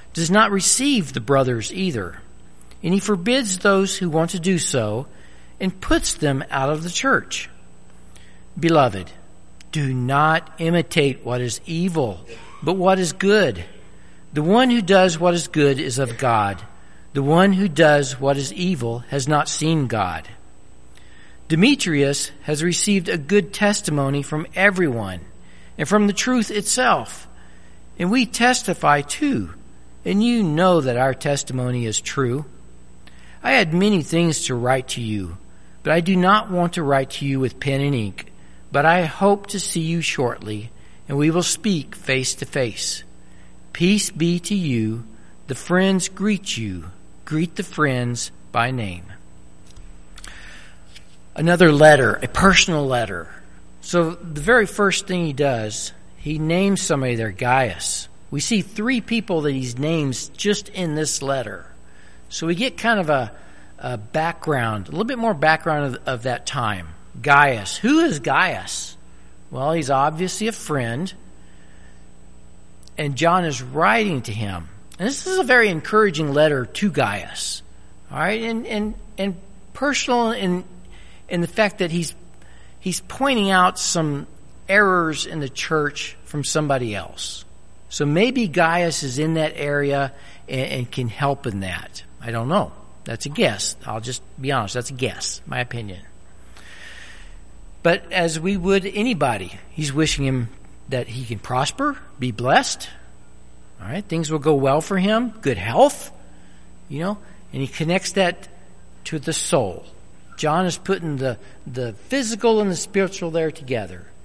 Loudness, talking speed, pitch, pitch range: -20 LUFS, 150 wpm, 150 Hz, 115-185 Hz